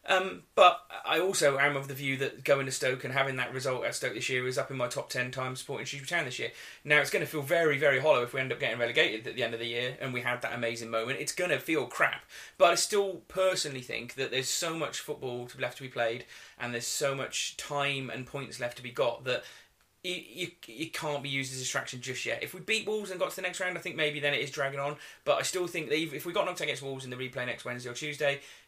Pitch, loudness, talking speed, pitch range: 140 Hz, -31 LUFS, 285 wpm, 125-155 Hz